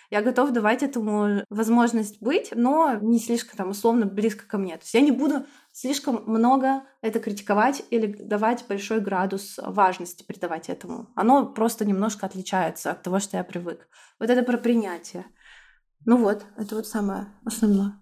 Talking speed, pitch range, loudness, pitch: 165 wpm, 200-235 Hz, -24 LUFS, 220 Hz